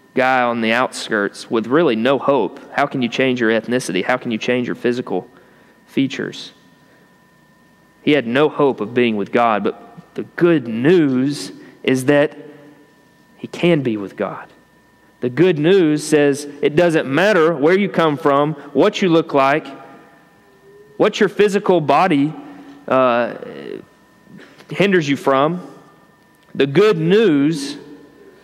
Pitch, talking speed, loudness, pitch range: 145 Hz, 140 wpm, -17 LUFS, 125-165 Hz